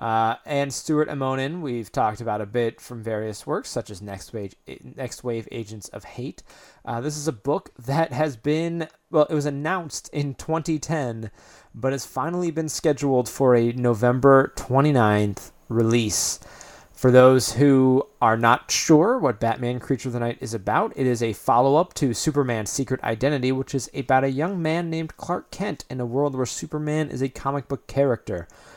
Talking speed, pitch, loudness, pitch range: 180 wpm, 130 Hz, -23 LUFS, 115-150 Hz